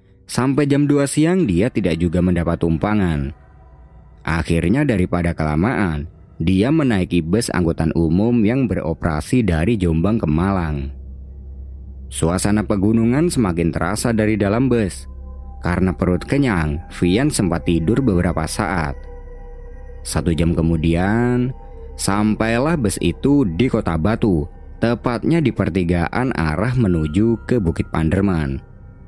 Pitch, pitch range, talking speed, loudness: 90 Hz, 80-110 Hz, 115 wpm, -18 LUFS